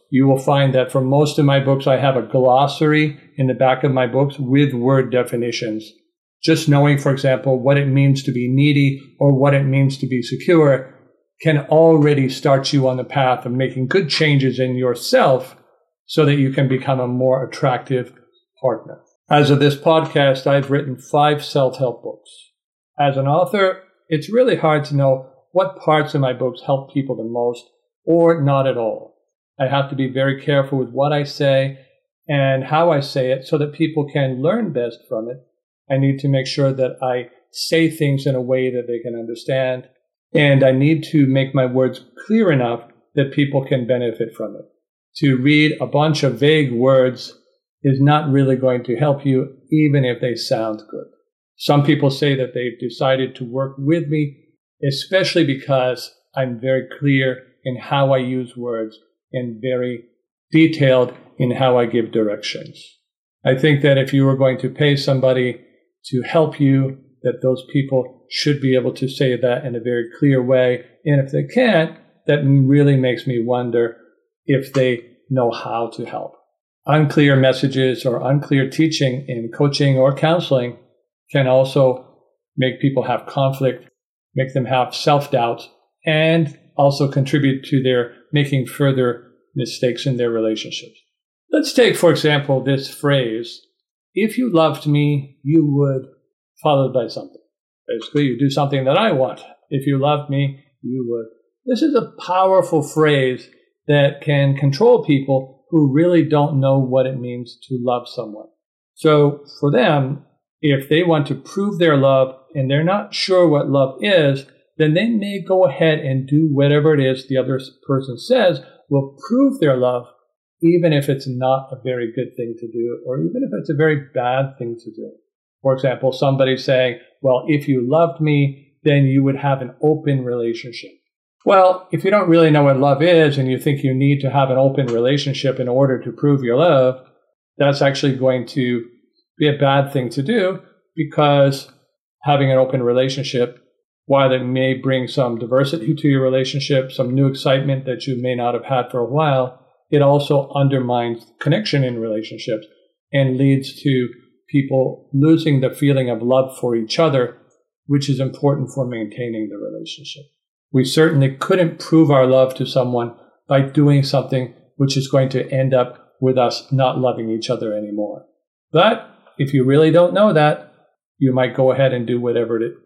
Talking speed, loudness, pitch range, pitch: 175 wpm, -17 LUFS, 130-150 Hz, 135 Hz